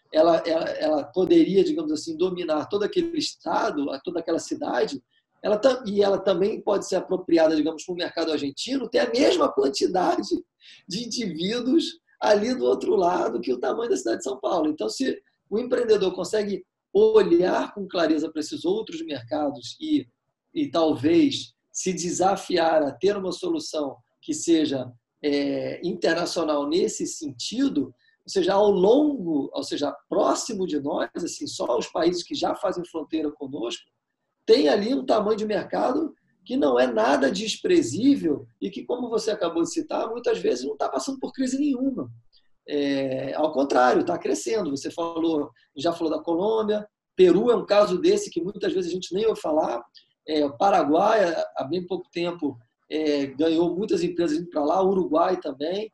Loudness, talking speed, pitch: -24 LUFS, 165 wpm, 205 Hz